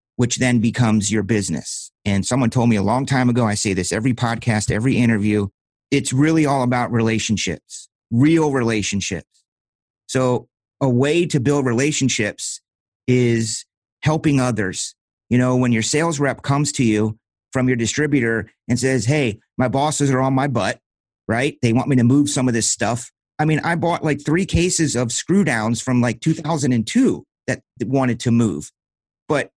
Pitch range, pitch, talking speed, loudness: 110-140 Hz, 125 Hz, 170 wpm, -19 LUFS